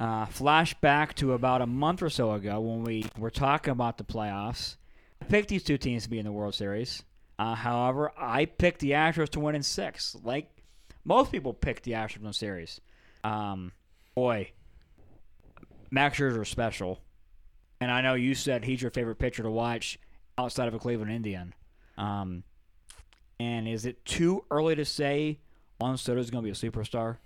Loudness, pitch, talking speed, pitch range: -30 LUFS, 115 Hz, 185 wpm, 105-135 Hz